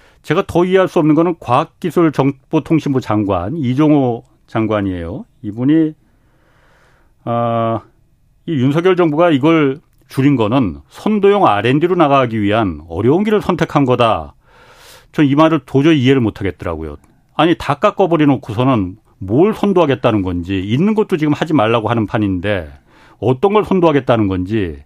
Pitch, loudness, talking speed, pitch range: 135 Hz, -14 LUFS, 320 characters per minute, 110-165 Hz